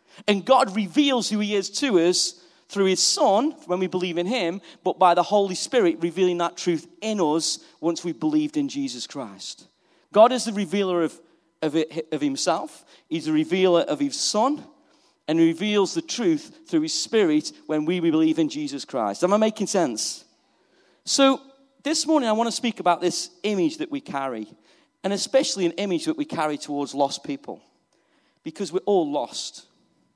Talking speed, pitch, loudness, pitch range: 185 wpm, 195 Hz, -23 LUFS, 170-275 Hz